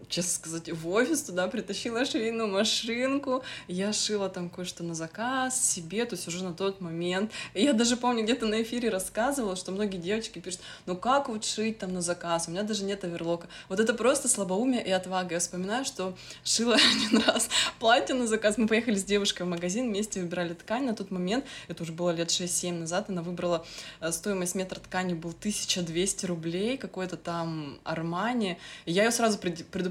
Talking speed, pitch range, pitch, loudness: 185 wpm, 175-225 Hz, 190 Hz, -29 LUFS